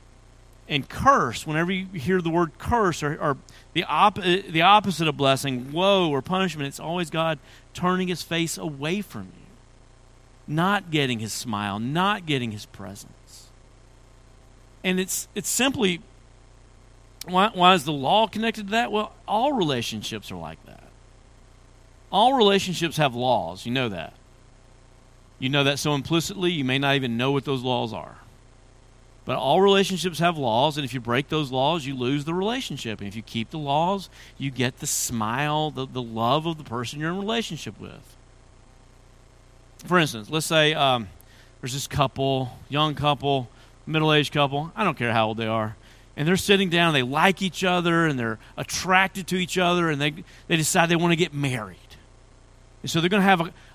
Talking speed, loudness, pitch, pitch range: 180 wpm, -23 LUFS, 140 Hz, 125-175 Hz